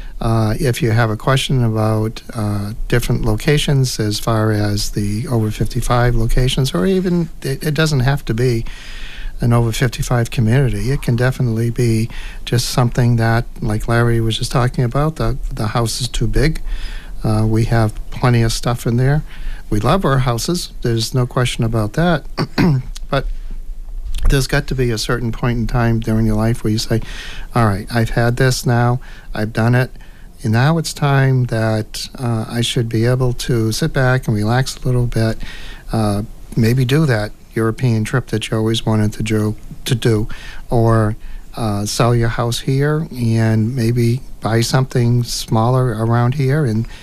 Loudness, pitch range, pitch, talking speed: -17 LUFS, 110-130 Hz, 120 Hz, 175 wpm